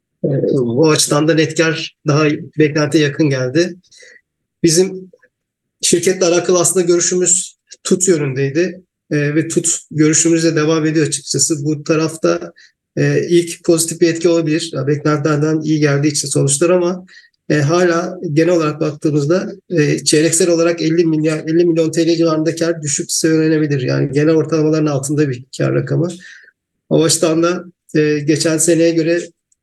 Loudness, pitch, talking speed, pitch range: -15 LUFS, 160 Hz, 130 wpm, 155-170 Hz